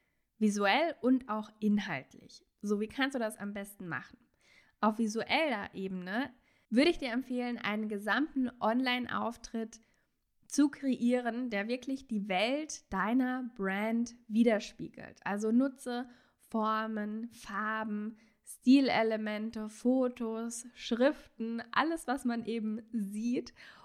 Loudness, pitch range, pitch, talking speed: -33 LUFS, 215-250 Hz, 230 Hz, 110 wpm